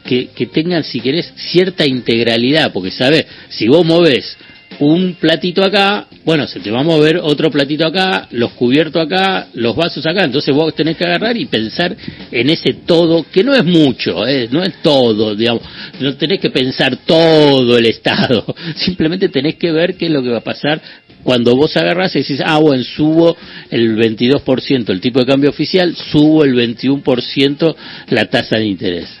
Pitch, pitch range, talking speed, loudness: 155 Hz, 130-170 Hz, 185 wpm, -13 LUFS